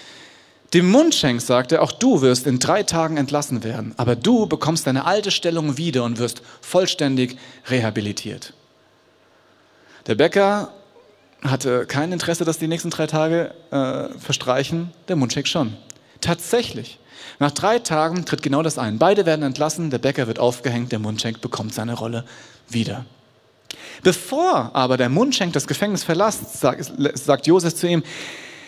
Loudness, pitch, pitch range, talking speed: -20 LUFS, 145 Hz, 125-170 Hz, 145 wpm